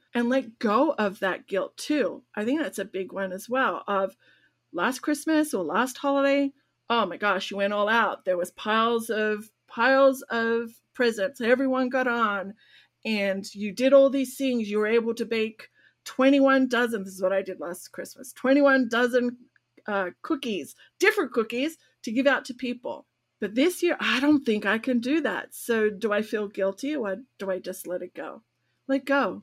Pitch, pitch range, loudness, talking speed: 235 Hz, 205-270 Hz, -25 LUFS, 190 wpm